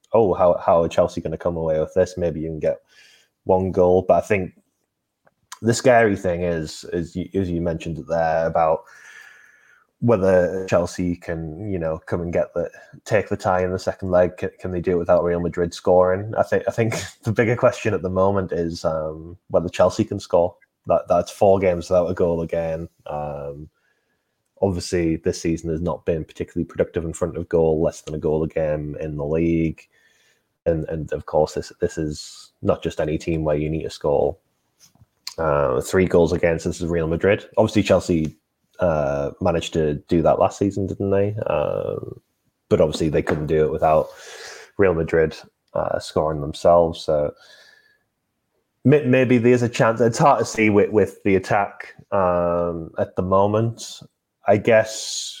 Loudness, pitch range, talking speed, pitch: -21 LUFS, 80-95 Hz, 185 wpm, 85 Hz